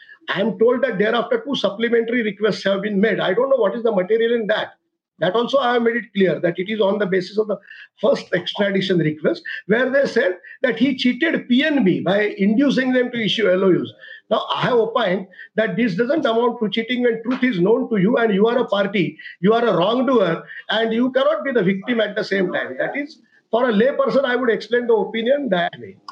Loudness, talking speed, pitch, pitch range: -19 LUFS, 225 wpm, 230 Hz, 205-255 Hz